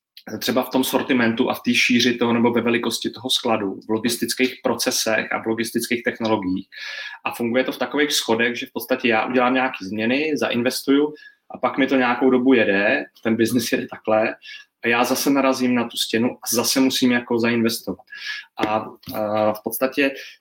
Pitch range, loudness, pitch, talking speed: 115-130 Hz, -20 LUFS, 125 Hz, 180 wpm